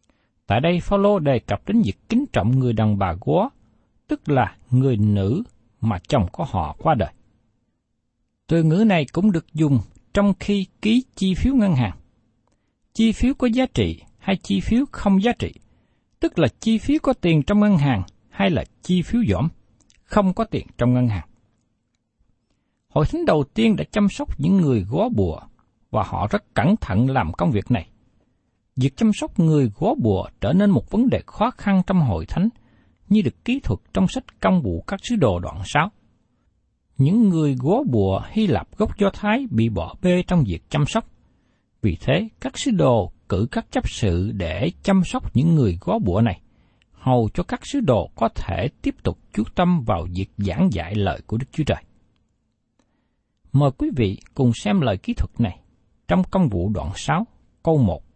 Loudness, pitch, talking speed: -21 LUFS, 130 Hz, 190 wpm